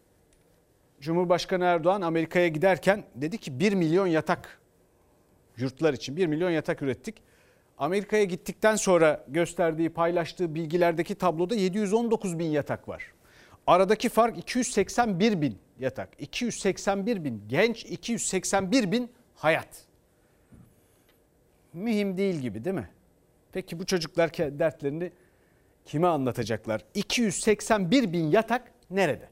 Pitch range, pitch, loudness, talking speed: 160-205 Hz, 180 Hz, -27 LUFS, 105 wpm